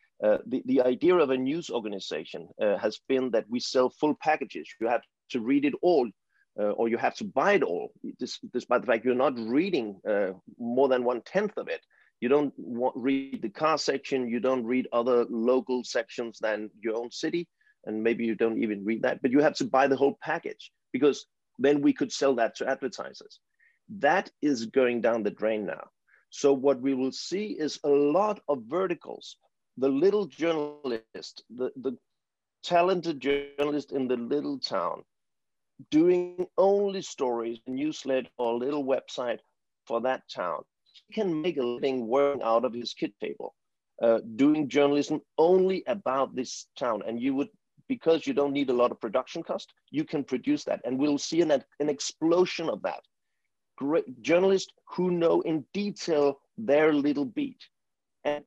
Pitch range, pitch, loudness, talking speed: 130-180 Hz, 145 Hz, -28 LUFS, 180 wpm